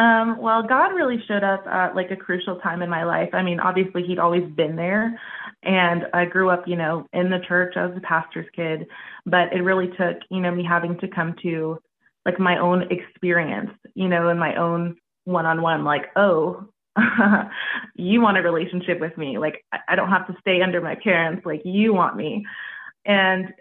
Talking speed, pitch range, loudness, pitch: 205 wpm, 170-190 Hz, -21 LUFS, 180 Hz